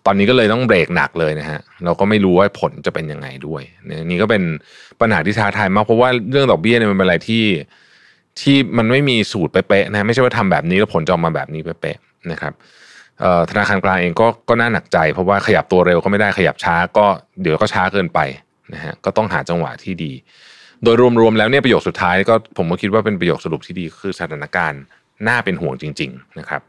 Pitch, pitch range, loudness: 100 Hz, 85-115 Hz, -16 LUFS